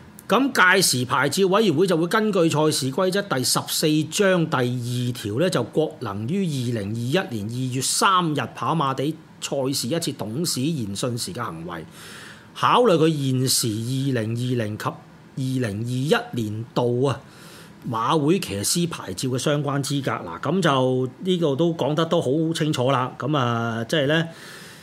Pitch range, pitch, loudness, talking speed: 125-170 Hz, 145 Hz, -22 LUFS, 240 characters per minute